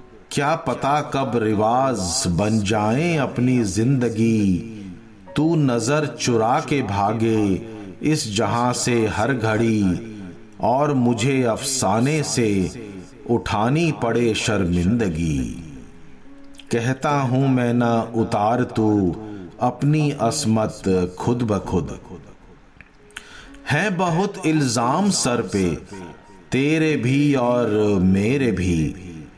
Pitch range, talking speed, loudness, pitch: 105-140 Hz, 95 wpm, -20 LUFS, 120 Hz